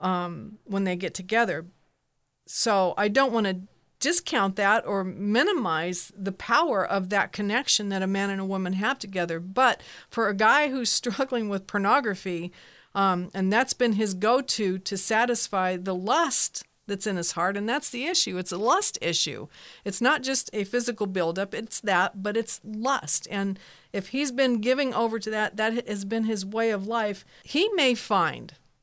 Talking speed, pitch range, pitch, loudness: 180 wpm, 190-240 Hz, 205 Hz, -25 LUFS